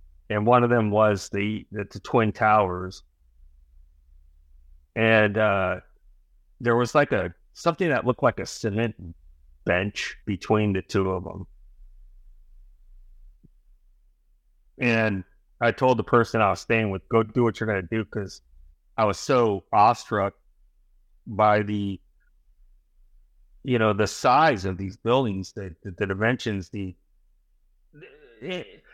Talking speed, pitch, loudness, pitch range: 135 wpm, 95 Hz, -24 LUFS, 70-110 Hz